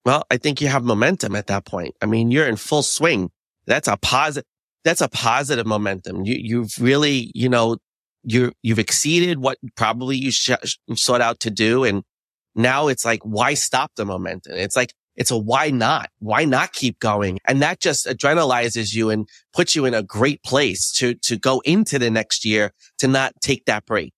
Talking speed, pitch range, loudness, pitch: 200 wpm, 110-135 Hz, -19 LUFS, 120 Hz